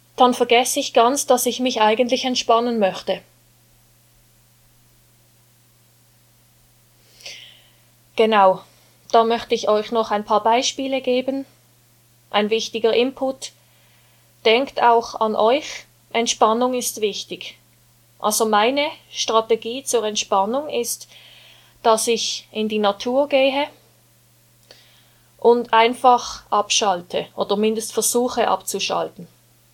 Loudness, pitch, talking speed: -19 LUFS, 215 Hz, 100 wpm